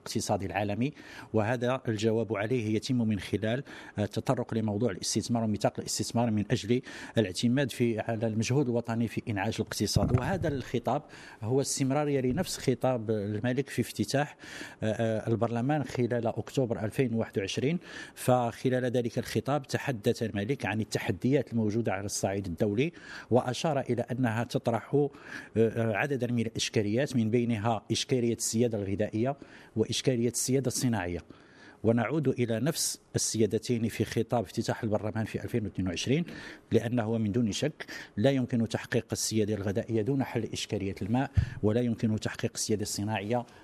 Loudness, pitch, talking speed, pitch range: -30 LUFS, 115 Hz, 125 wpm, 110-125 Hz